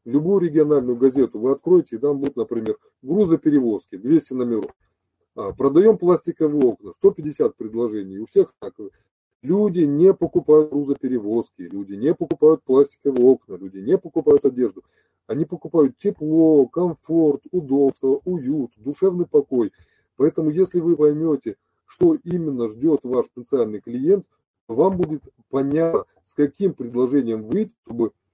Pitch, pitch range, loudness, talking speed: 150 Hz, 130-180 Hz, -20 LUFS, 125 wpm